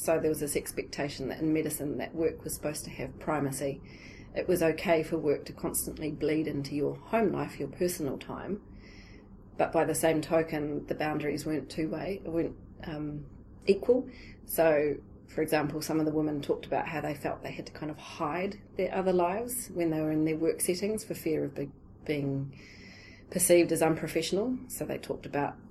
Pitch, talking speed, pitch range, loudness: 155 Hz, 190 wpm, 140-165 Hz, -31 LUFS